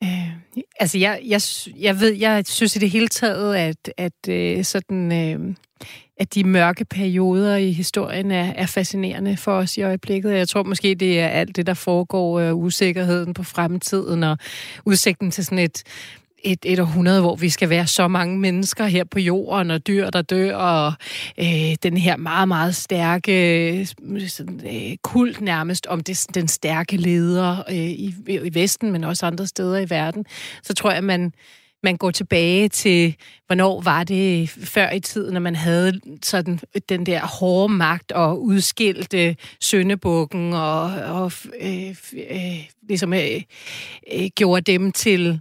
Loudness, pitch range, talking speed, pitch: -20 LUFS, 170-195 Hz, 170 wpm, 185 Hz